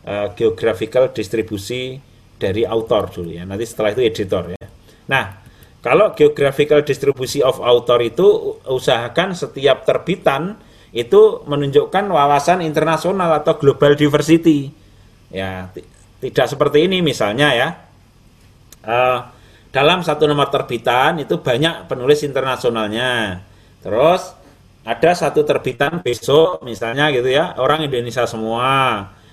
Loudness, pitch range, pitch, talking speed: -16 LUFS, 115-150 Hz, 130 Hz, 115 wpm